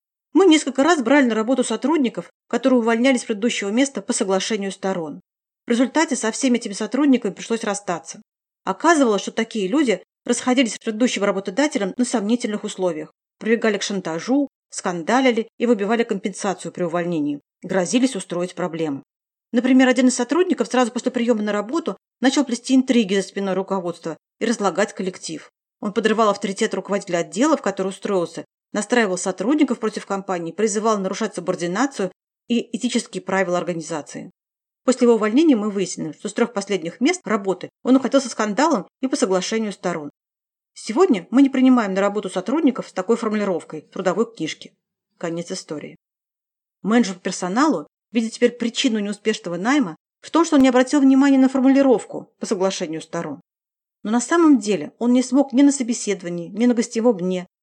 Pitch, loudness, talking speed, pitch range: 220 Hz, -20 LUFS, 155 wpm, 190-255 Hz